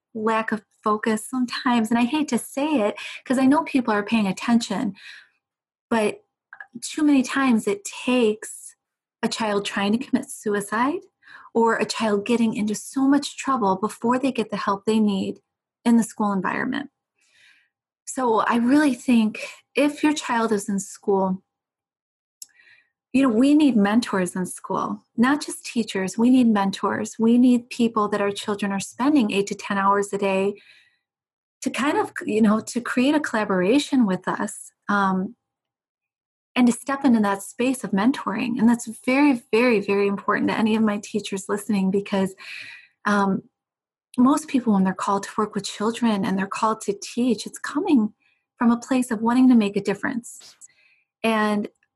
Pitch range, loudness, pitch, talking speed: 205-255 Hz, -22 LUFS, 225 Hz, 165 wpm